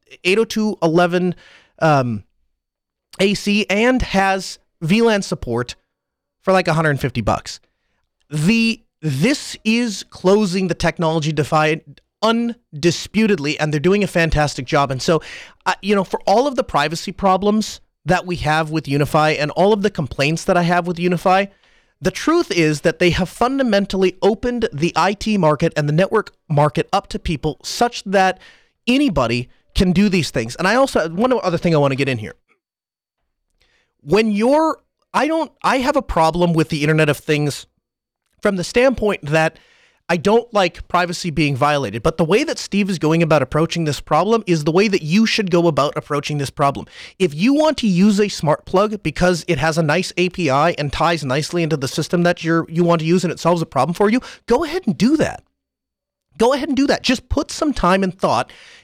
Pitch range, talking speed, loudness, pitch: 155-210 Hz, 185 wpm, -18 LUFS, 175 Hz